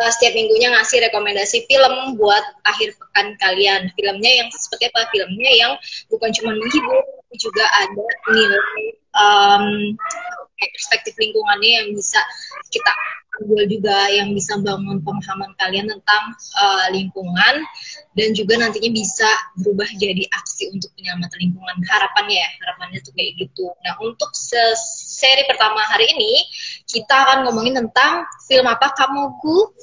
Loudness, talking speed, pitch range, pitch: -16 LUFS, 135 wpm, 200-270 Hz, 220 Hz